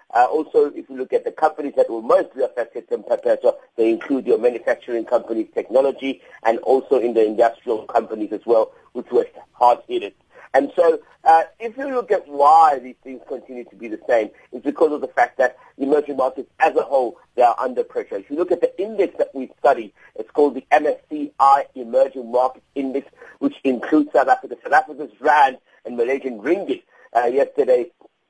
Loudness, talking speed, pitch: -20 LUFS, 190 wpm, 295 Hz